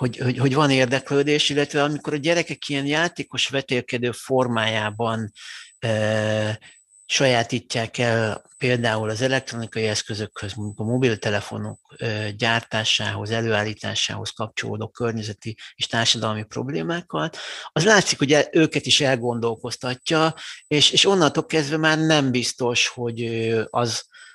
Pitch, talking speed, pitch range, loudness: 120 Hz, 110 wpm, 110-145 Hz, -22 LUFS